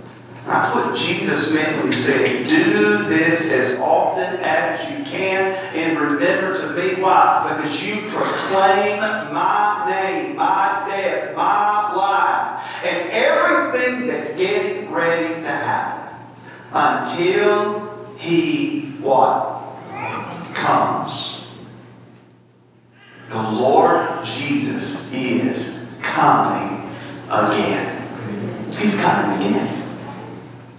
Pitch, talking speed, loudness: 190 Hz, 95 wpm, -18 LUFS